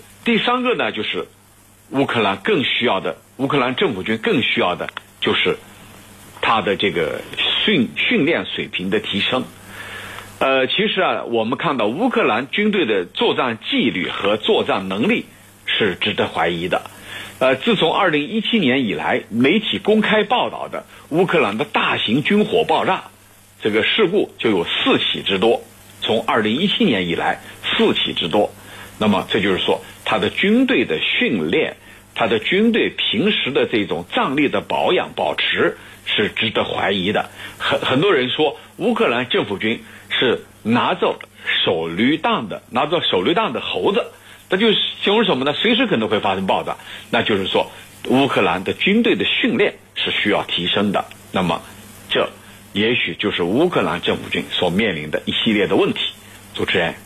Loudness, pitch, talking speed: -18 LUFS, 160 Hz, 250 characters per minute